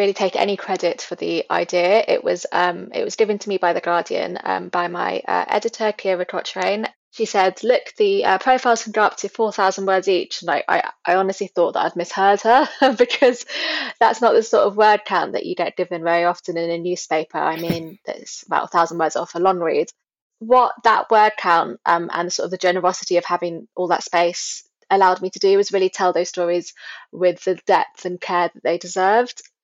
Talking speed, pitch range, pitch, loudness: 220 wpm, 175-215 Hz, 185 Hz, -19 LUFS